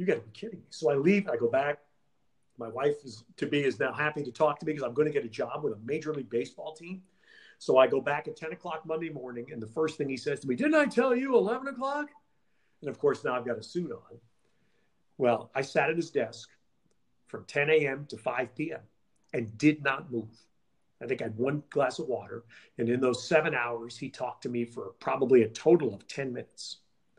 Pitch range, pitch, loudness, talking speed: 125-160 Hz, 145 Hz, -30 LUFS, 240 wpm